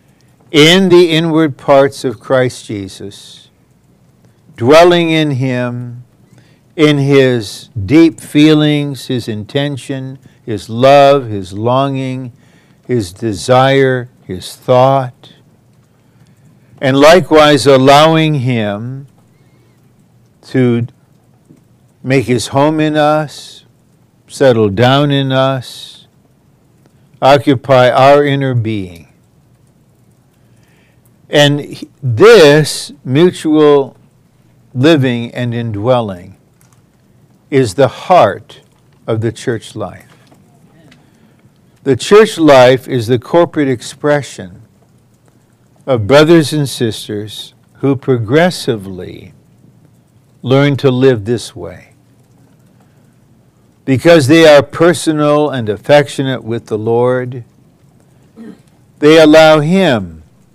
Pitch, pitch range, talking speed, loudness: 135 Hz, 120-150 Hz, 85 wpm, -10 LUFS